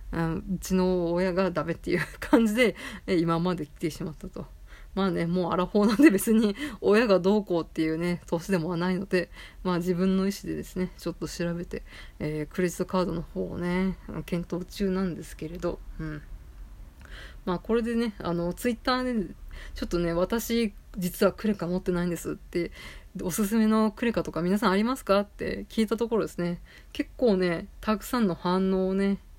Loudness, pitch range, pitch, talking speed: -27 LUFS, 170-205 Hz, 185 Hz, 365 characters per minute